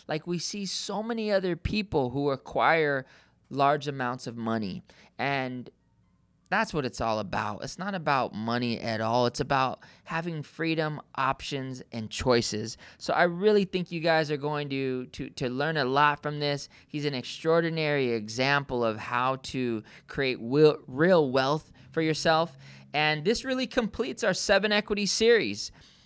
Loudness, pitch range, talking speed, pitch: -28 LUFS, 125-165 Hz, 155 wpm, 145 Hz